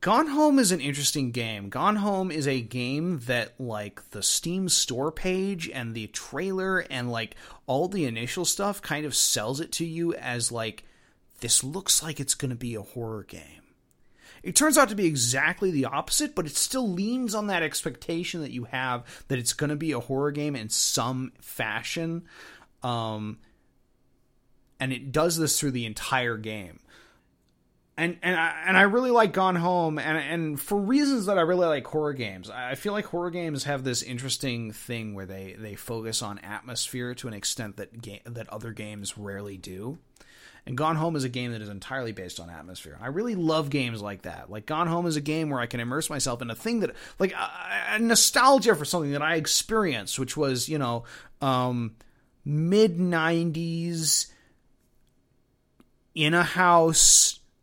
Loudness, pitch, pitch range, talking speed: -26 LUFS, 140 Hz, 115-170 Hz, 185 wpm